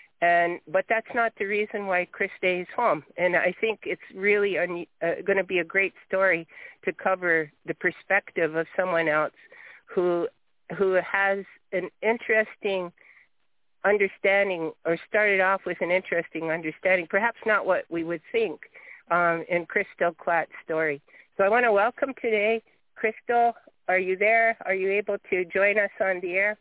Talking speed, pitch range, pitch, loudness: 160 wpm, 175-210 Hz, 190 Hz, -25 LUFS